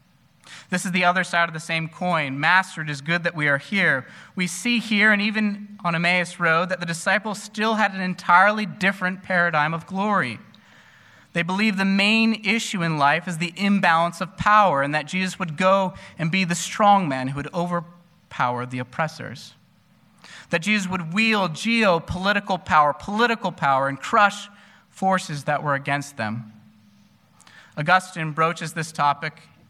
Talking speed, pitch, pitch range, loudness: 165 wpm, 175 Hz, 155-195 Hz, -21 LUFS